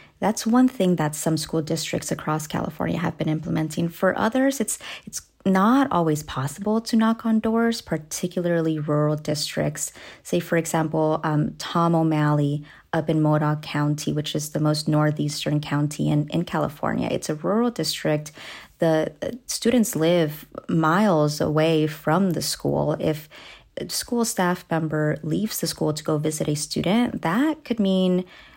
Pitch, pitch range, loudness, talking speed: 160 Hz, 150-190 Hz, -23 LUFS, 155 wpm